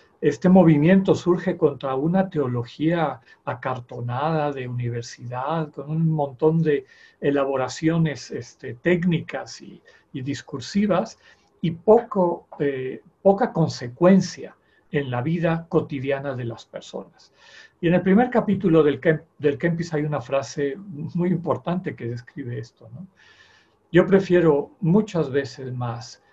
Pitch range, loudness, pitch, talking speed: 135-175 Hz, -22 LUFS, 155 Hz, 120 wpm